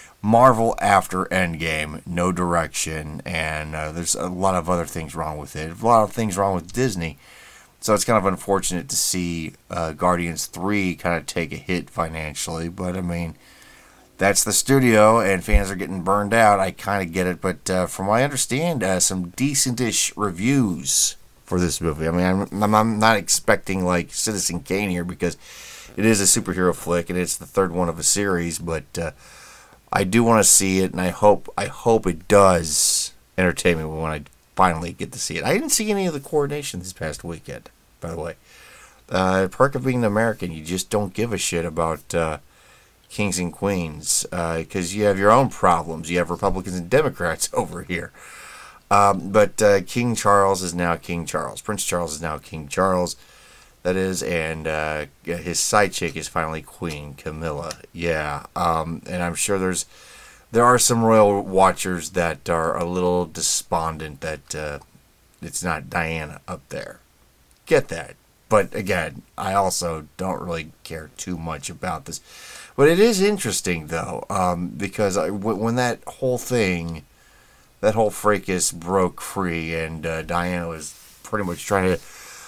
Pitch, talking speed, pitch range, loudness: 90 Hz, 180 wpm, 85-100 Hz, -21 LUFS